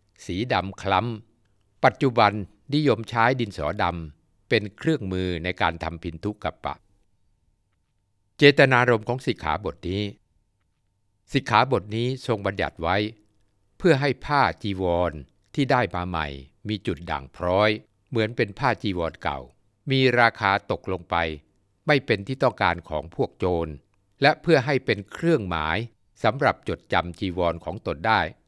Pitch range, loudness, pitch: 90-115 Hz, -24 LUFS, 100 Hz